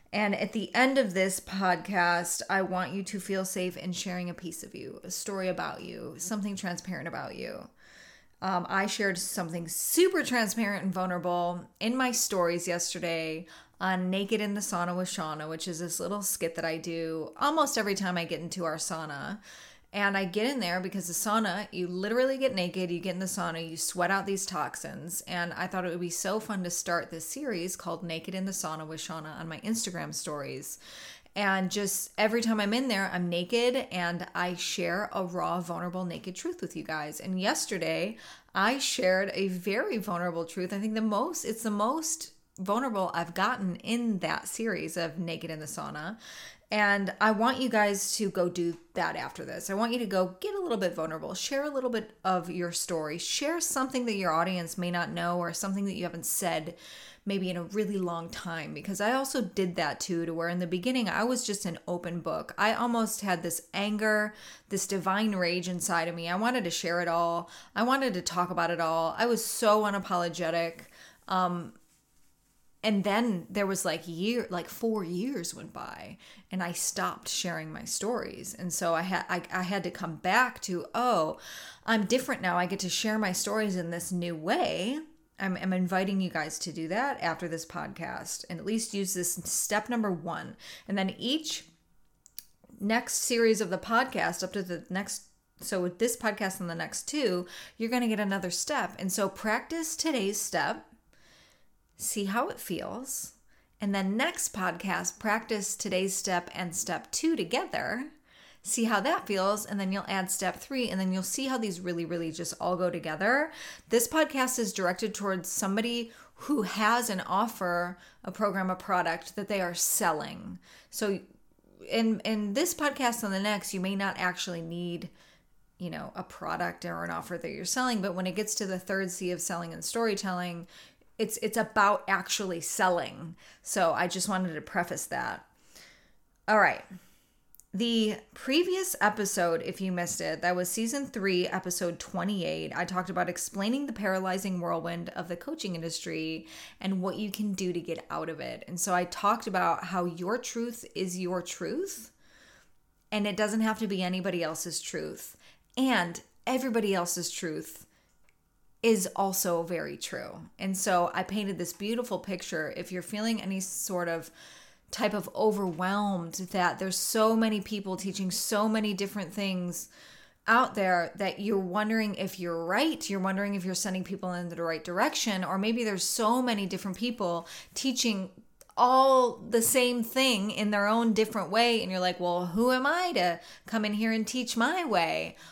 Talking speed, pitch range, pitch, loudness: 190 wpm, 175-220 Hz, 190 Hz, -30 LUFS